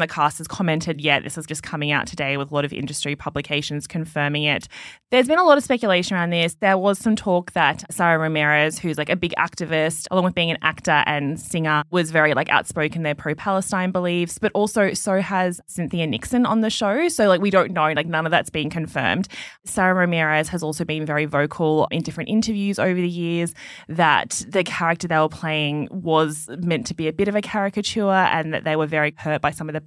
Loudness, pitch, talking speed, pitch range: -21 LUFS, 165 Hz, 225 wpm, 155-185 Hz